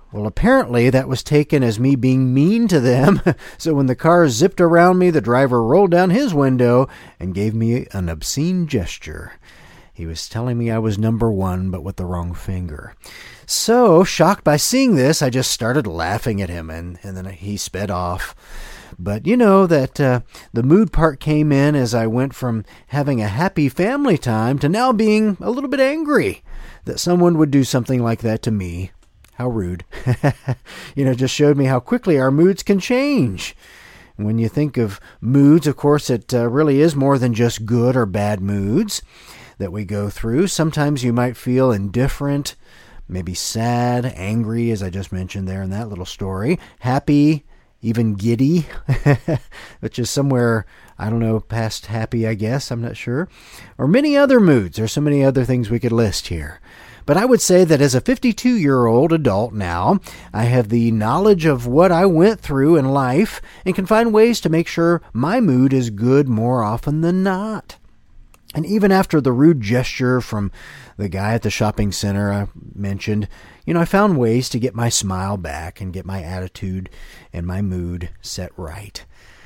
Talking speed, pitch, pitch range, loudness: 190 wpm, 125 Hz, 105-155 Hz, -17 LUFS